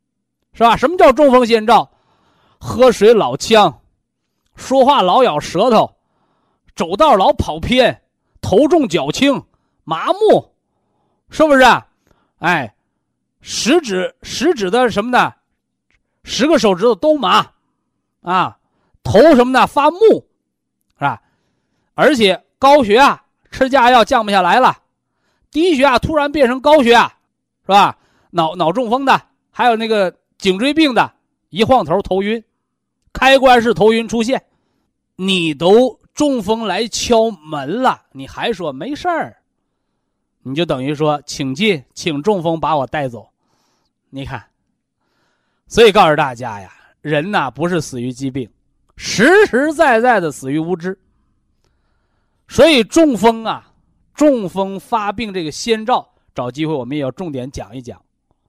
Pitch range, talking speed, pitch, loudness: 170-270 Hz, 195 characters per minute, 230 Hz, -14 LUFS